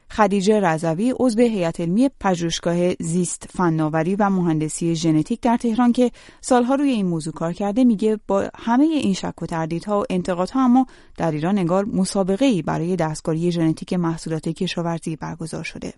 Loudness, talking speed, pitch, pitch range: -21 LUFS, 160 wpm, 190 Hz, 165-235 Hz